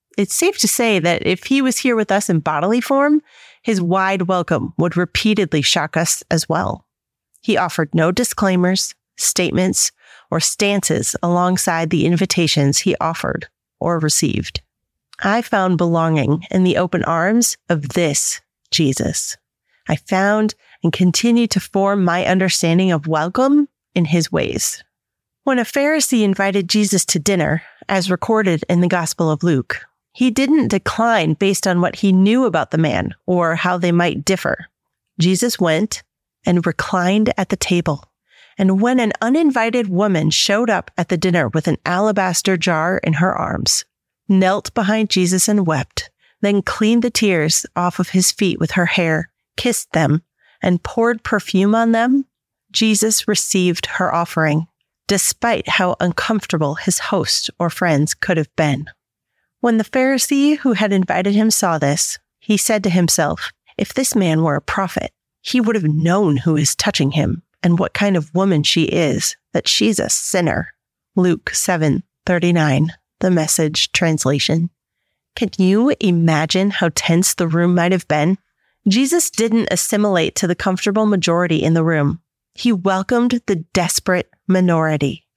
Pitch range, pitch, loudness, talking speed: 165-210 Hz, 185 Hz, -17 LUFS, 155 wpm